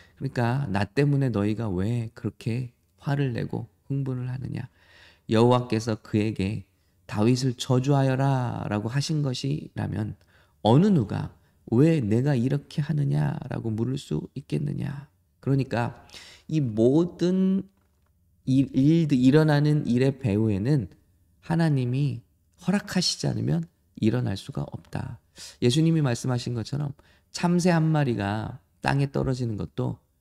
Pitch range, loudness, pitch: 105-145 Hz, -25 LUFS, 125 Hz